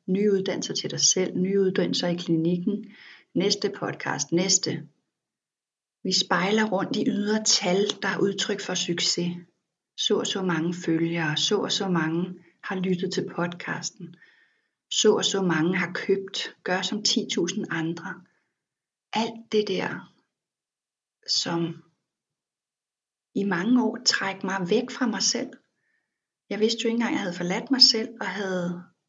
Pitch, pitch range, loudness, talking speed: 190 Hz, 175-215 Hz, -25 LUFS, 145 wpm